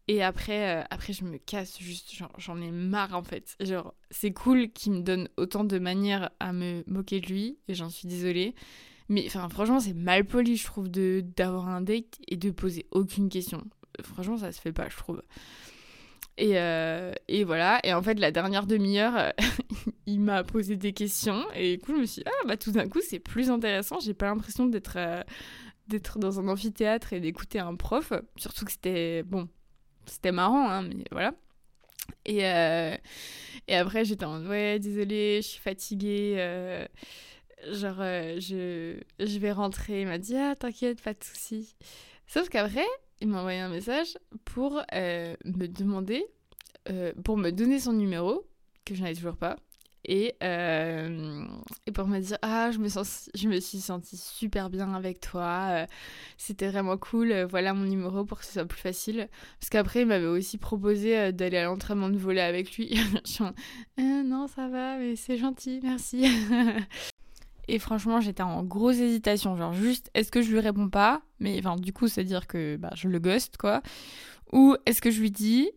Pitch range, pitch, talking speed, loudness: 185-225 Hz, 200 Hz, 190 wpm, -29 LUFS